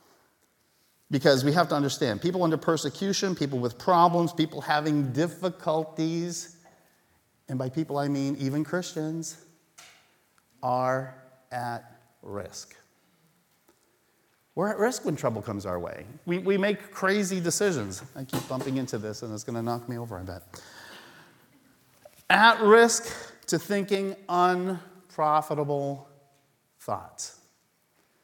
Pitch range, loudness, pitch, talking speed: 130-175 Hz, -27 LUFS, 150 Hz, 120 wpm